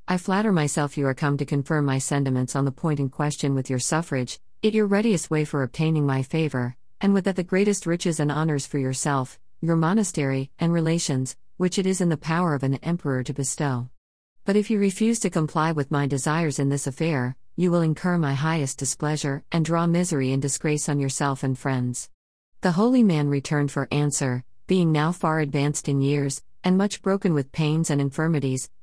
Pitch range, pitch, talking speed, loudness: 135-170 Hz, 150 Hz, 200 wpm, -24 LUFS